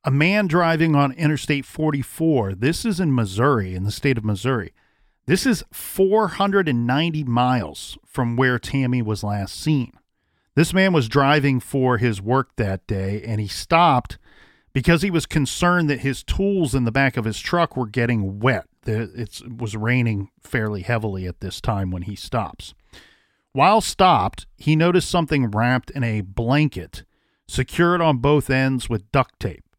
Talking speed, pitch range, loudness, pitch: 160 wpm, 110-150 Hz, -21 LUFS, 130 Hz